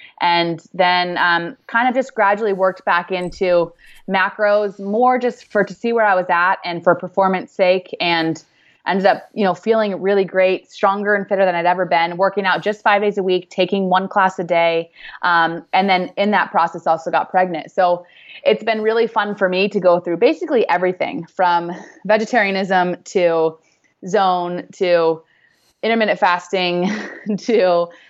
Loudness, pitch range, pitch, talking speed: -17 LUFS, 175-205 Hz, 185 Hz, 170 wpm